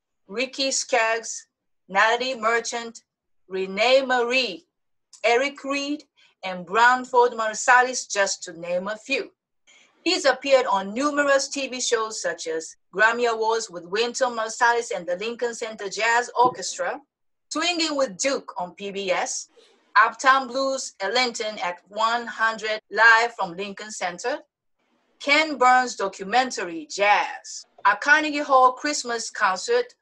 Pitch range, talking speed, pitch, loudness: 215-270 Hz, 115 wpm, 240 Hz, -22 LUFS